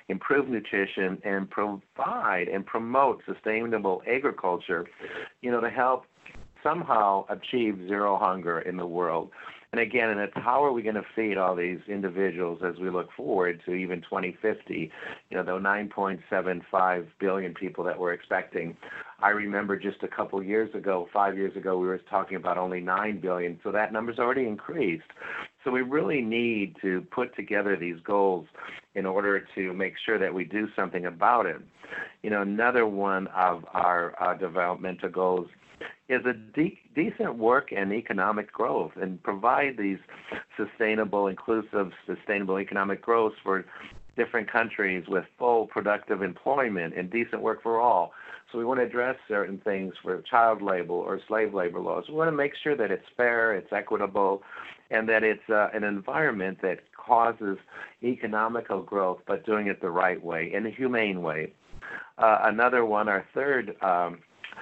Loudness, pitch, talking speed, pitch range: -28 LUFS, 100 Hz, 165 wpm, 95-110 Hz